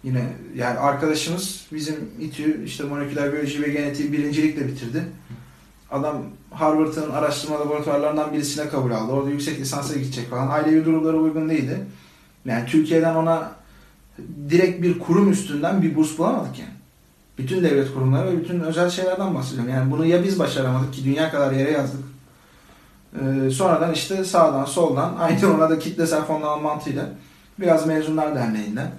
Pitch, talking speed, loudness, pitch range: 150 Hz, 145 wpm, -22 LUFS, 135-160 Hz